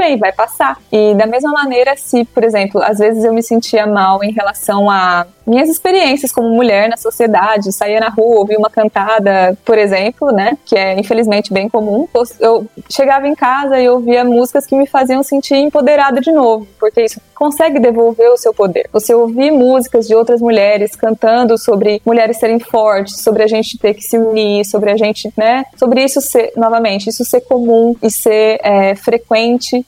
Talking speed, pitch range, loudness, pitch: 185 wpm, 215-250 Hz, -11 LUFS, 230 Hz